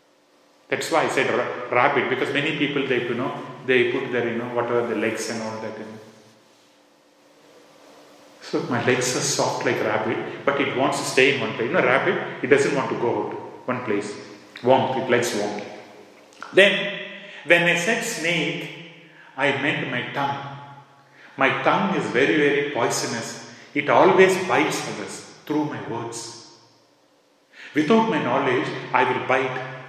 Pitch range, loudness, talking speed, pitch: 115-155 Hz, -22 LUFS, 165 wpm, 130 Hz